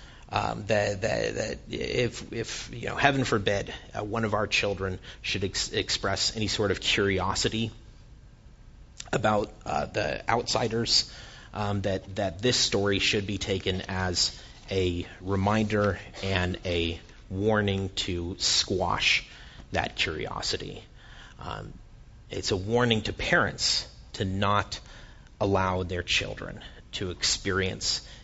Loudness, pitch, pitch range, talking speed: -27 LUFS, 100 Hz, 95-110 Hz, 120 wpm